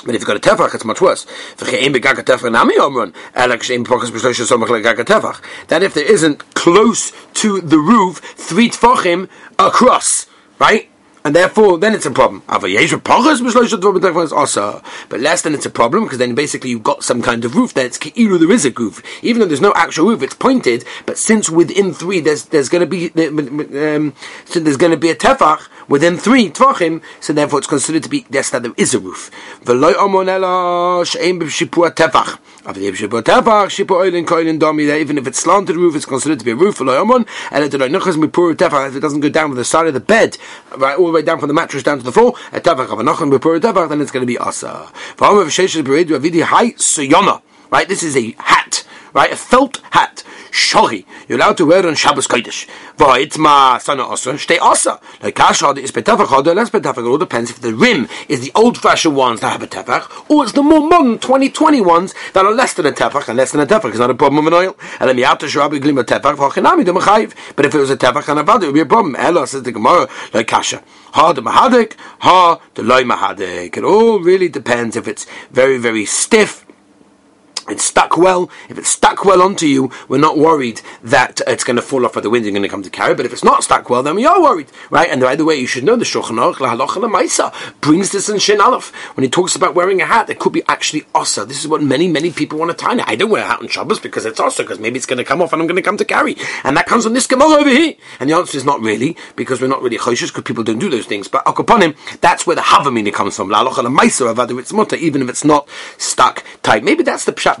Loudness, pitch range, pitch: -13 LUFS, 145-220 Hz, 170 Hz